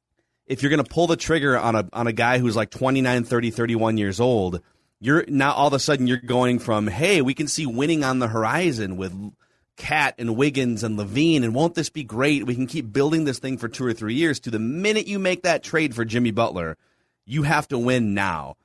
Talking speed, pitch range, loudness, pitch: 235 wpm, 115-150 Hz, -22 LUFS, 125 Hz